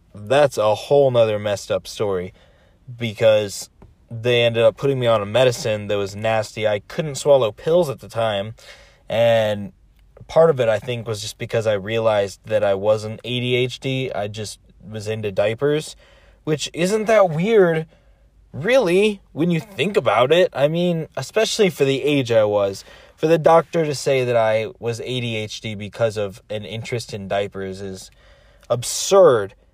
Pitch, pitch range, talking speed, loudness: 115 Hz, 105-145 Hz, 165 wpm, -19 LUFS